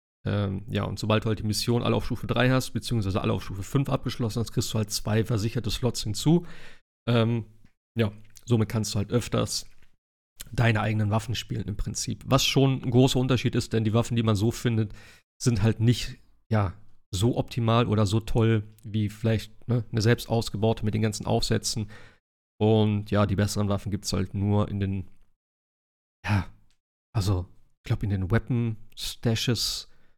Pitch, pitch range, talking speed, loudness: 110 Hz, 105-120 Hz, 180 wpm, -27 LUFS